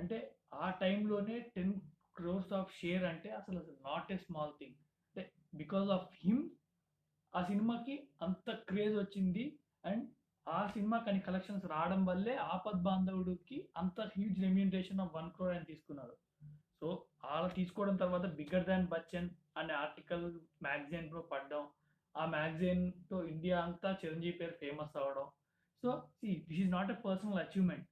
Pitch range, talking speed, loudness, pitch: 165-195 Hz, 140 wpm, -40 LUFS, 180 Hz